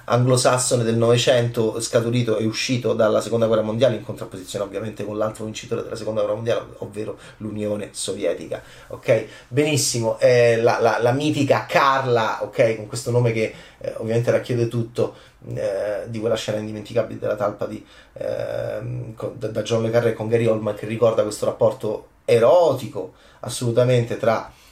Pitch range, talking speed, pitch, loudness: 110-120 Hz, 155 wpm, 115 Hz, -21 LUFS